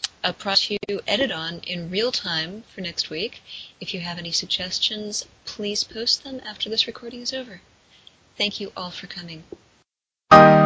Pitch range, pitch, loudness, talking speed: 175-220 Hz, 200 Hz, -22 LUFS, 165 wpm